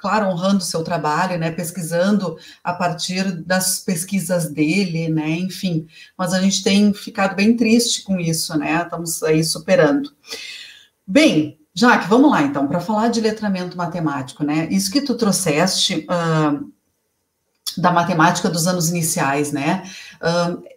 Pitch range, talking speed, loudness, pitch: 165-195 Hz, 145 wpm, -18 LUFS, 180 Hz